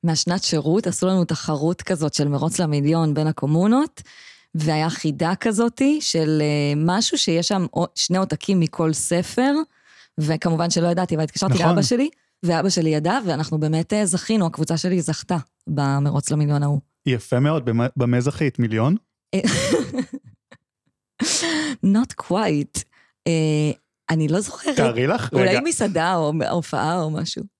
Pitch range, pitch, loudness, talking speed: 155-190 Hz, 165 Hz, -21 LUFS, 130 wpm